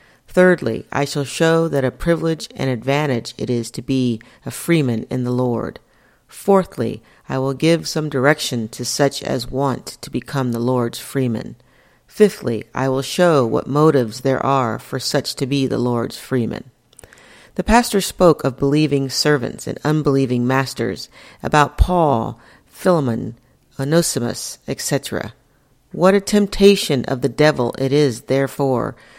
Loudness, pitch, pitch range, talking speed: -18 LUFS, 135 Hz, 125-155 Hz, 145 wpm